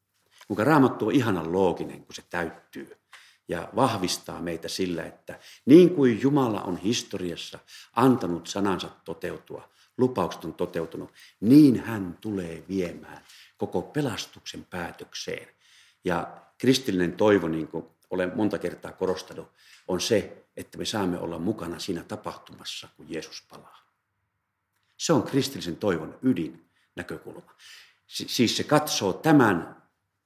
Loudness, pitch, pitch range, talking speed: -26 LUFS, 95 Hz, 85-115 Hz, 125 wpm